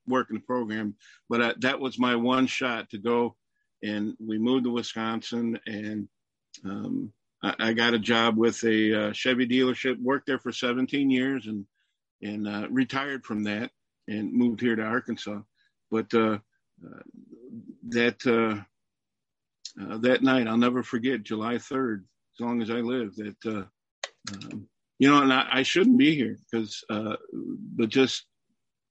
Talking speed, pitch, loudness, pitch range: 160 wpm, 120 Hz, -26 LUFS, 110-130 Hz